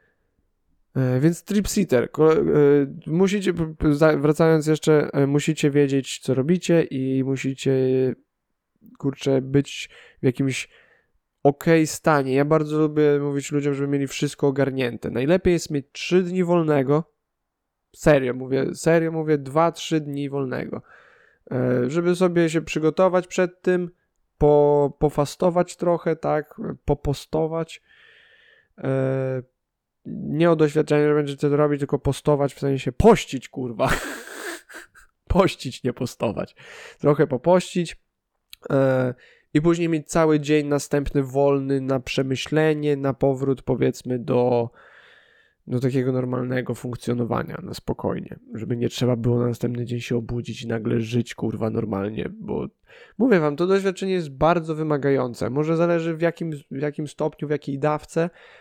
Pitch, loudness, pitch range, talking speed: 145 Hz, -22 LUFS, 130-165 Hz, 125 wpm